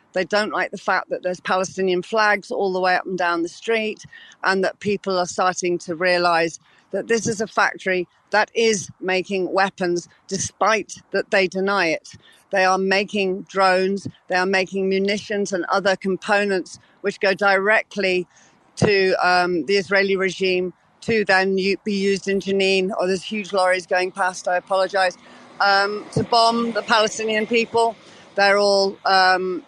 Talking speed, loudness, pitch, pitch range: 160 wpm, -20 LUFS, 190 Hz, 185-200 Hz